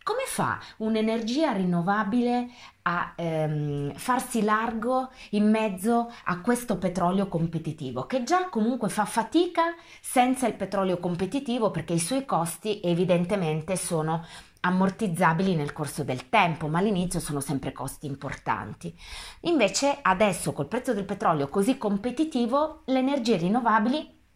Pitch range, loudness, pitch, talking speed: 170-245 Hz, -26 LUFS, 205 Hz, 125 wpm